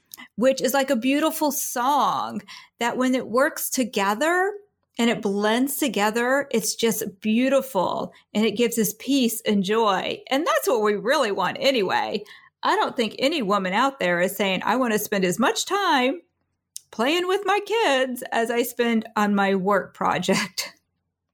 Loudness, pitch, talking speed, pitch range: -22 LUFS, 240 Hz, 165 wpm, 210-275 Hz